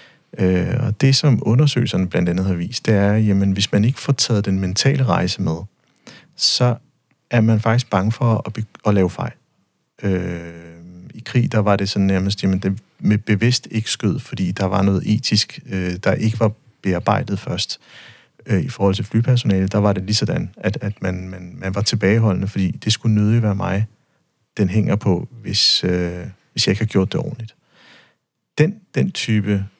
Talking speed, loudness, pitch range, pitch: 190 wpm, -19 LUFS, 95-115 Hz, 105 Hz